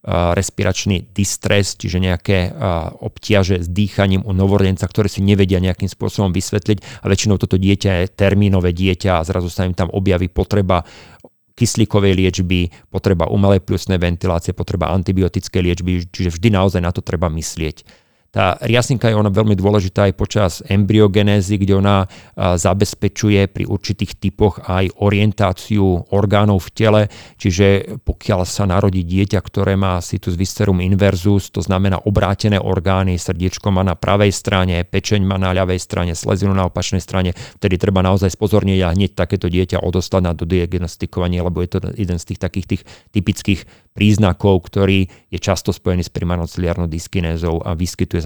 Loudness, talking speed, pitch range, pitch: -17 LUFS, 155 wpm, 90-100 Hz, 95 Hz